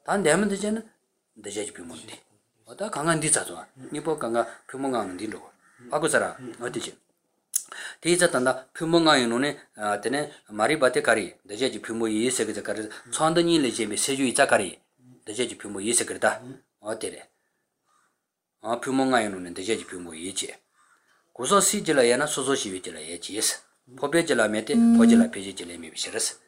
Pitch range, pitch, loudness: 115-170 Hz, 140 Hz, -25 LUFS